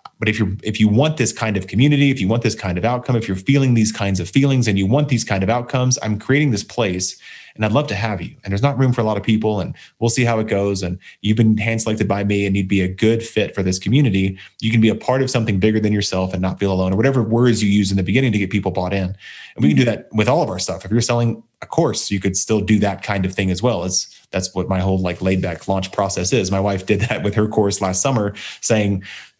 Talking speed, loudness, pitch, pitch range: 295 wpm, -18 LUFS, 105 Hz, 95-115 Hz